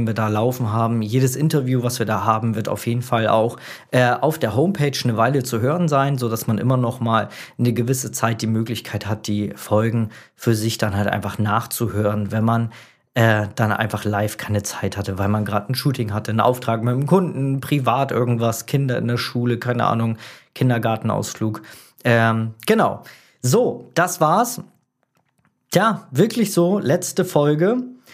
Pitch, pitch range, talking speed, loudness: 115 Hz, 110-130 Hz, 175 wpm, -20 LUFS